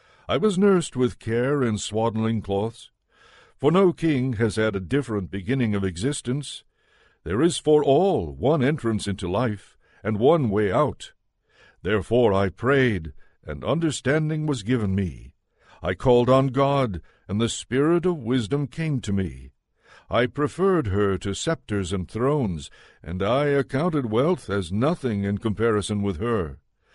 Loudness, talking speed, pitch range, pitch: -23 LUFS, 150 wpm, 100-140 Hz, 120 Hz